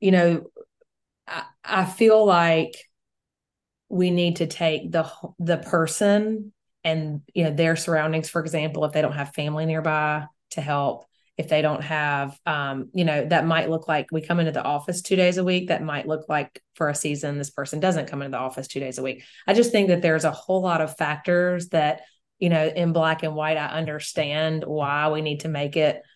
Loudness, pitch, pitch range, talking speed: -23 LUFS, 160 Hz, 150-175 Hz, 210 wpm